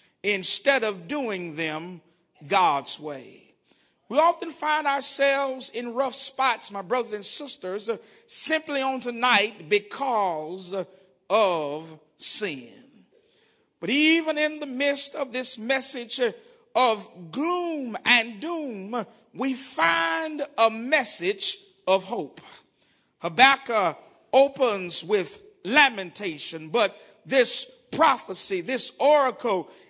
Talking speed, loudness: 100 wpm, -24 LUFS